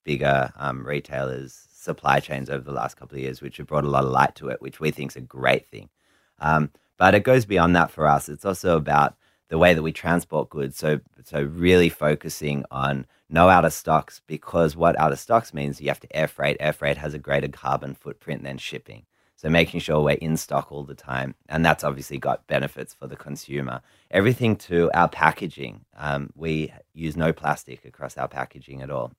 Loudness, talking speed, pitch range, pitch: -23 LUFS, 215 wpm, 70-80 Hz, 75 Hz